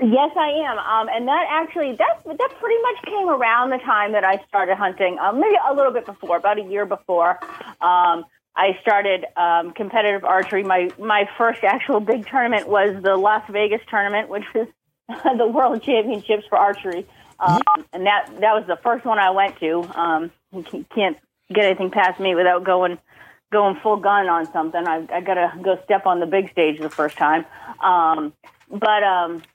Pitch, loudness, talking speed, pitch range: 200 Hz, -19 LUFS, 185 wpm, 180-225 Hz